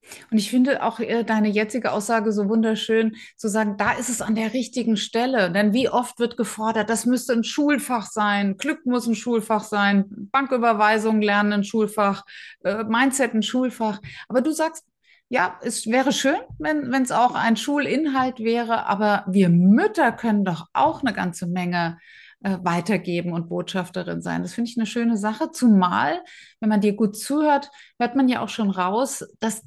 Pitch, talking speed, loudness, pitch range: 225 Hz, 175 wpm, -22 LUFS, 205-250 Hz